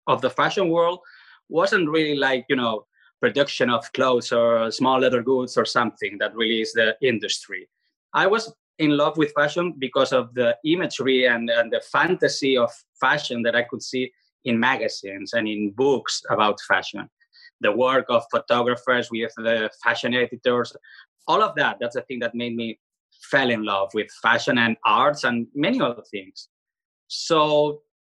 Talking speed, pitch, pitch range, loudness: 170 wpm, 125 Hz, 115-145 Hz, -22 LUFS